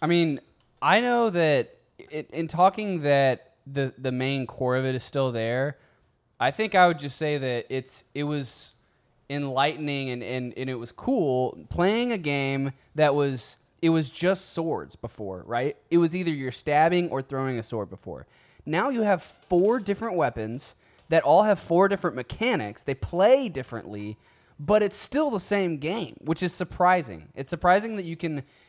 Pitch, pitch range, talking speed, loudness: 145 Hz, 130-180 Hz, 180 wpm, -25 LUFS